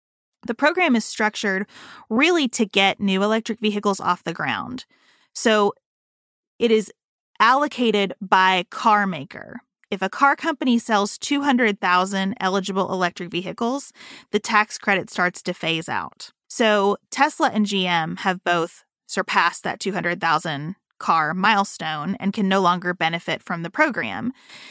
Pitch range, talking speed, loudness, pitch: 180-235 Hz, 135 wpm, -21 LUFS, 200 Hz